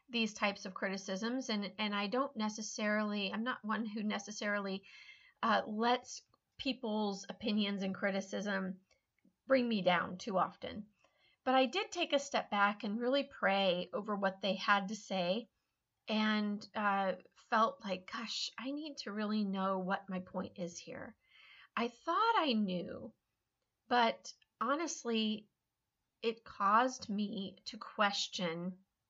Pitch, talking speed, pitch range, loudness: 210 Hz, 140 wpm, 195-240 Hz, -36 LUFS